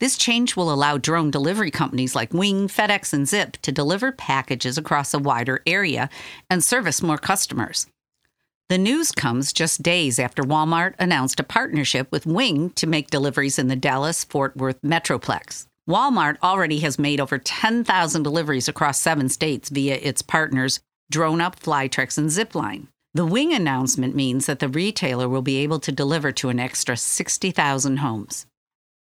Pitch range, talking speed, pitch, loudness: 135-170 Hz, 160 wpm, 150 Hz, -21 LUFS